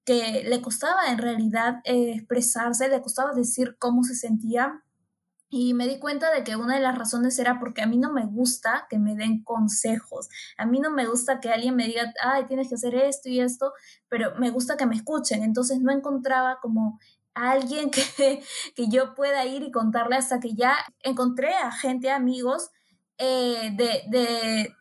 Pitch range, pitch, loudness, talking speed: 235-265 Hz, 250 Hz, -25 LUFS, 190 wpm